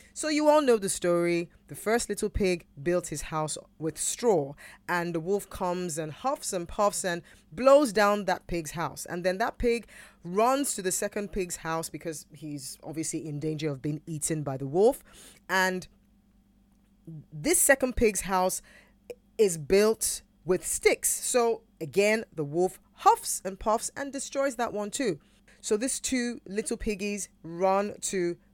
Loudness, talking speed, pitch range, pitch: -28 LUFS, 165 wpm, 165-220 Hz, 190 Hz